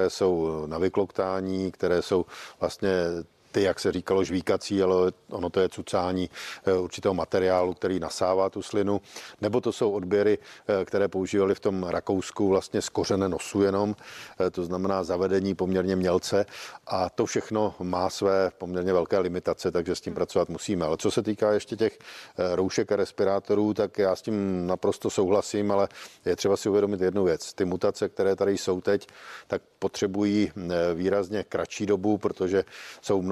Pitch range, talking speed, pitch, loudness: 90-100 Hz, 160 wpm, 95 Hz, -27 LUFS